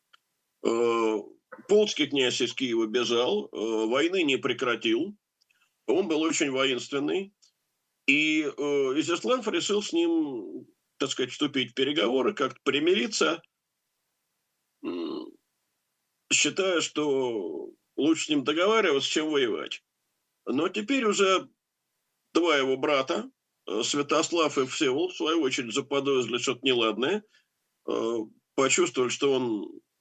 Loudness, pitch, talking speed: -26 LUFS, 205 Hz, 100 wpm